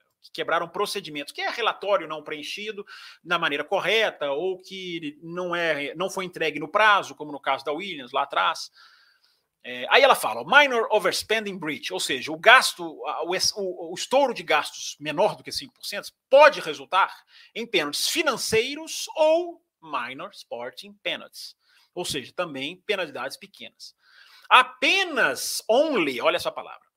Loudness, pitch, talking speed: -23 LUFS, 195 Hz, 145 wpm